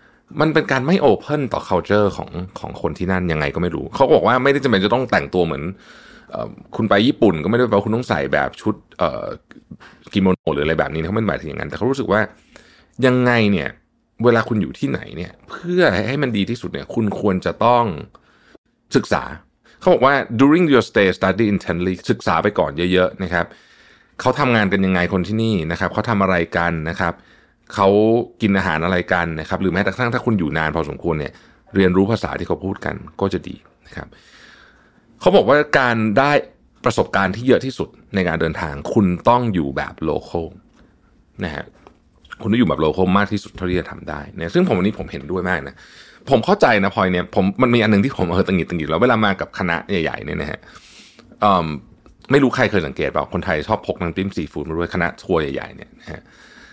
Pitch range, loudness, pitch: 90-115 Hz, -18 LUFS, 95 Hz